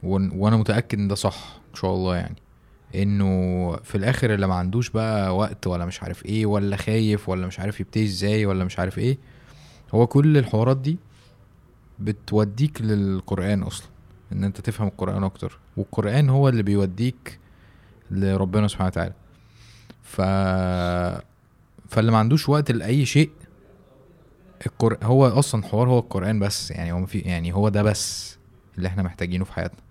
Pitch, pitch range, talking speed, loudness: 100 Hz, 95-115 Hz, 155 wpm, -23 LUFS